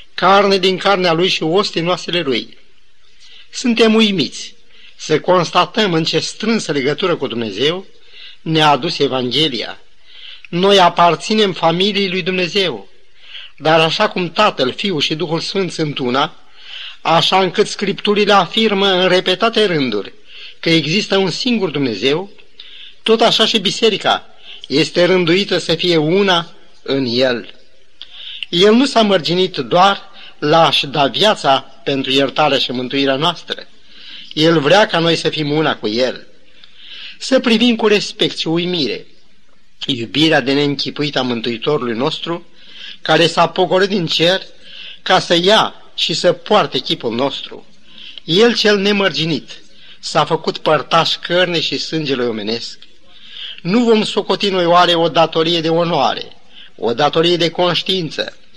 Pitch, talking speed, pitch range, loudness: 175 Hz, 130 wpm, 155-200 Hz, -14 LUFS